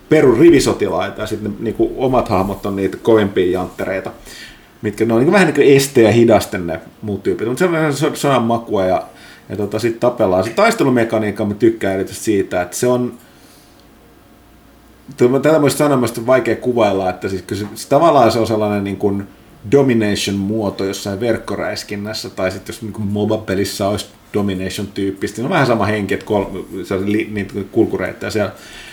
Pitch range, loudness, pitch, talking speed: 100-120 Hz, -16 LUFS, 105 Hz, 170 wpm